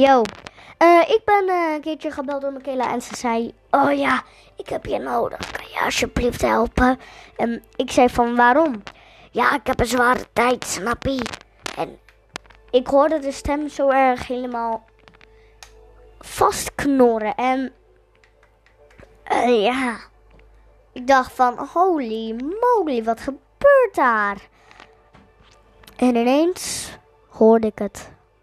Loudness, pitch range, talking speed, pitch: -20 LUFS, 235-285 Hz, 130 wpm, 255 Hz